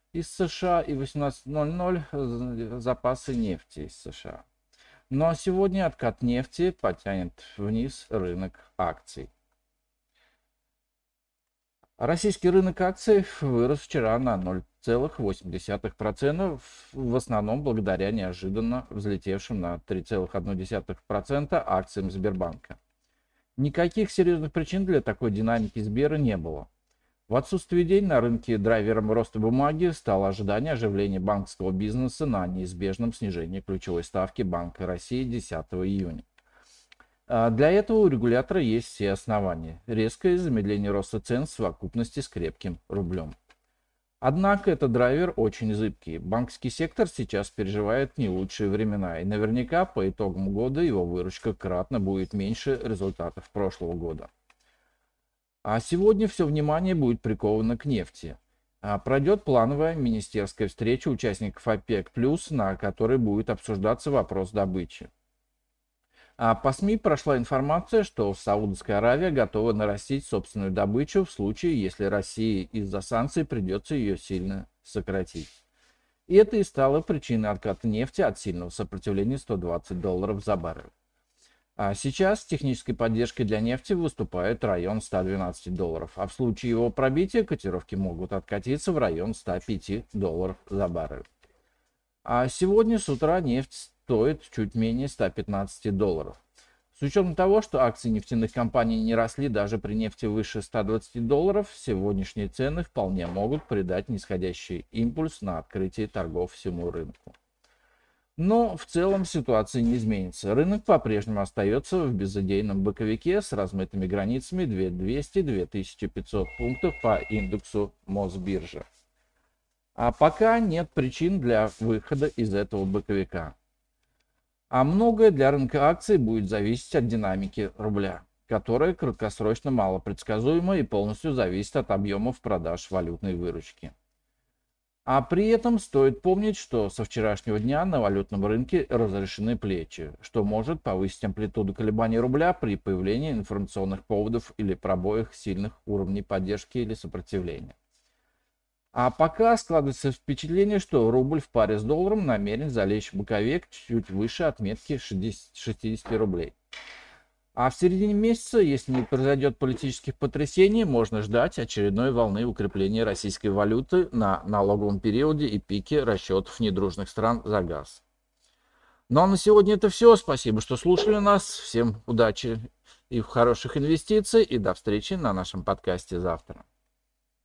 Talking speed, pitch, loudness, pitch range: 125 wpm, 115 Hz, -27 LUFS, 100-140 Hz